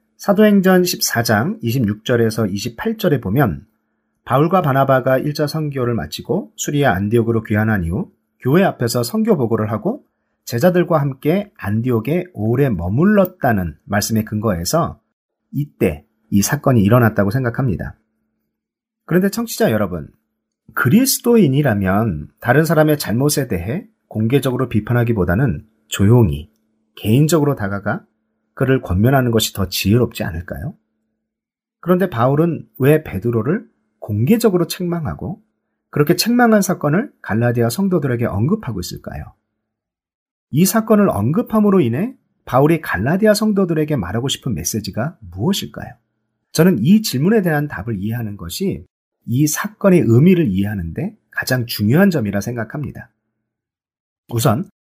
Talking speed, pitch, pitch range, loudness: 310 characters per minute, 125 Hz, 110-170 Hz, -17 LUFS